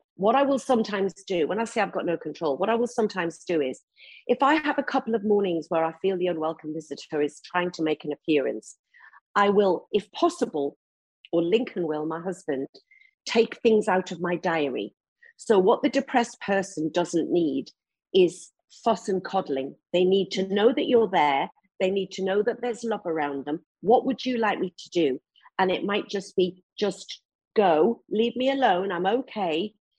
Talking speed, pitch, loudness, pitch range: 195 wpm, 195 Hz, -25 LUFS, 175-240 Hz